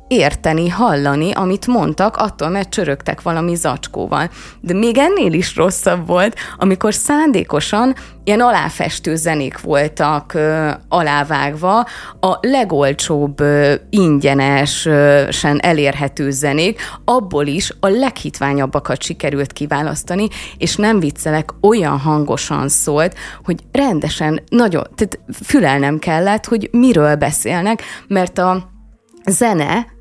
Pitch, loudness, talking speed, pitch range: 165 Hz, -15 LUFS, 105 wpm, 145-210 Hz